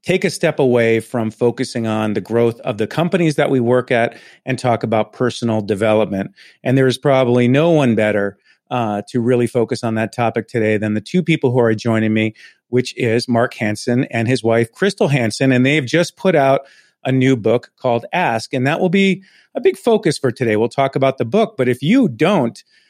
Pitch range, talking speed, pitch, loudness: 115-145 Hz, 215 wpm, 125 Hz, -17 LUFS